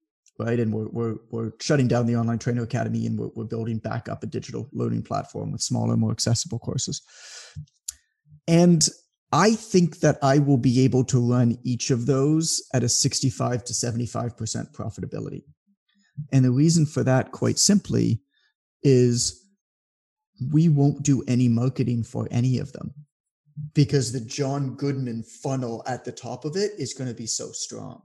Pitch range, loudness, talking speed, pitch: 115-150 Hz, -23 LUFS, 165 wpm, 130 Hz